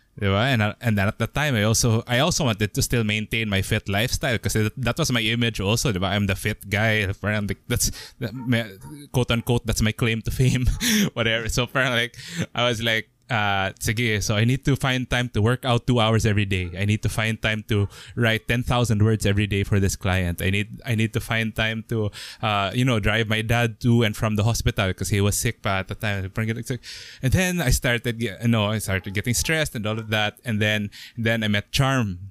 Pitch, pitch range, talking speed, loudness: 110 Hz, 105-120 Hz, 215 wpm, -23 LUFS